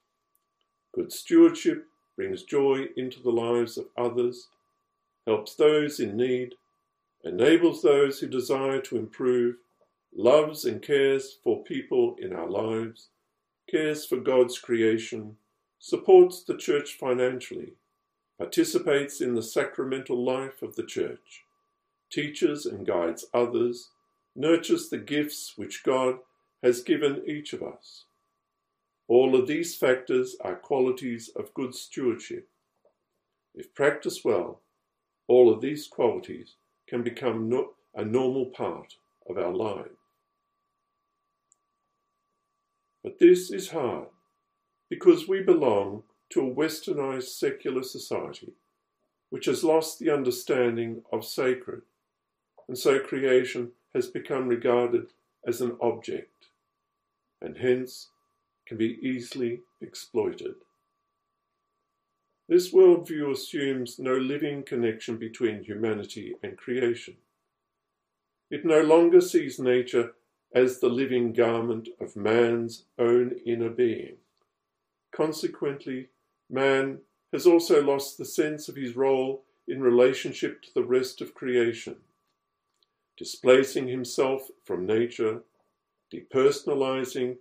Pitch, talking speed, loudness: 150 Hz, 110 wpm, -26 LUFS